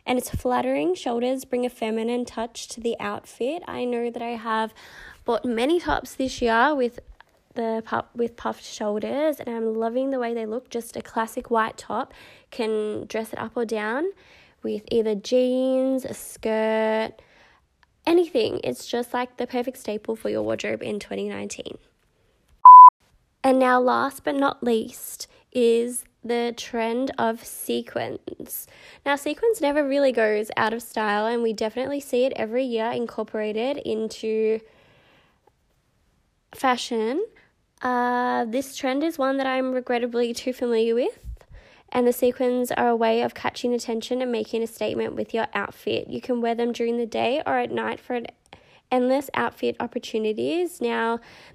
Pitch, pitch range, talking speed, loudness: 240 Hz, 225-260 Hz, 155 wpm, -23 LUFS